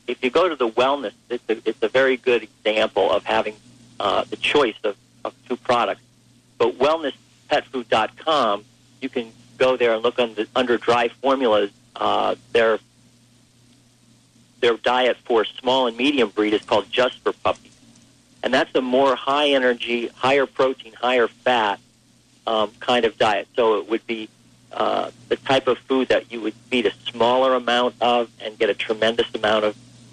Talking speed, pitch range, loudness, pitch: 170 wpm, 115-125 Hz, -21 LUFS, 120 Hz